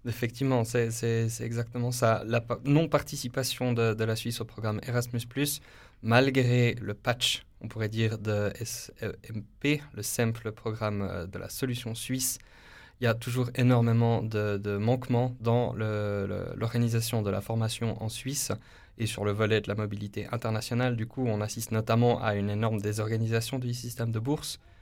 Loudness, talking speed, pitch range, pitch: -29 LUFS, 165 wpm, 110-120 Hz, 115 Hz